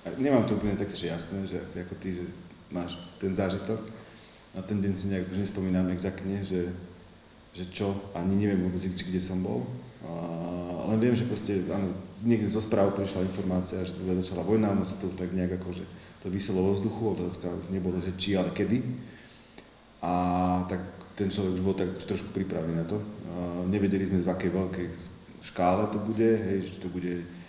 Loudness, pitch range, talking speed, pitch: -30 LUFS, 90-100 Hz, 200 wpm, 95 Hz